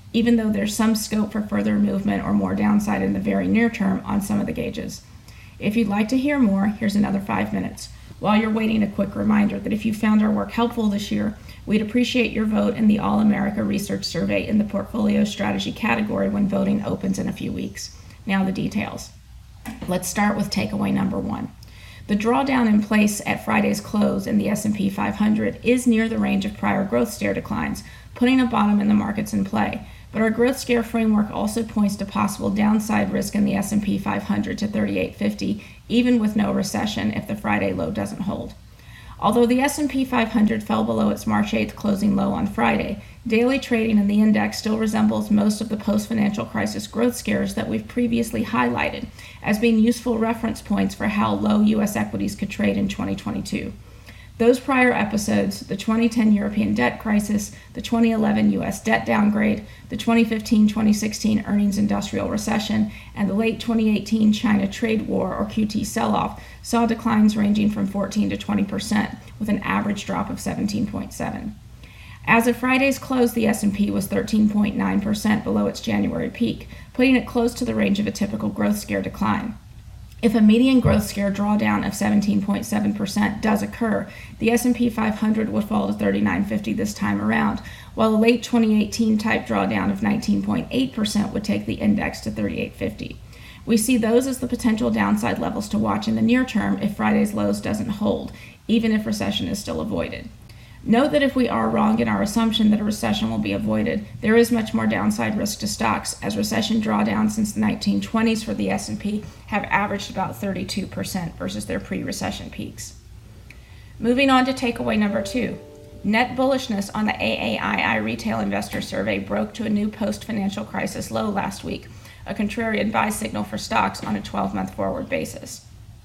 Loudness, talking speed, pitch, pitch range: -22 LUFS, 180 wpm, 215 Hz, 205-225 Hz